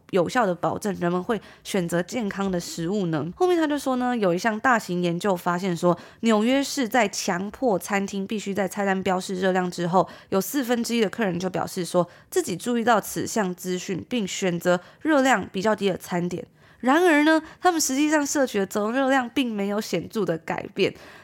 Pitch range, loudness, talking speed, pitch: 180-245 Hz, -24 LUFS, 295 characters per minute, 200 Hz